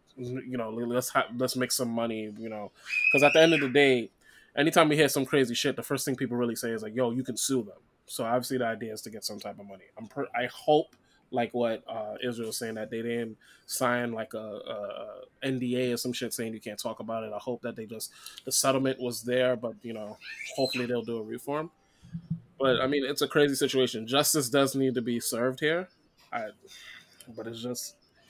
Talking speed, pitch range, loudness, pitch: 230 wpm, 115-135 Hz, -29 LUFS, 125 Hz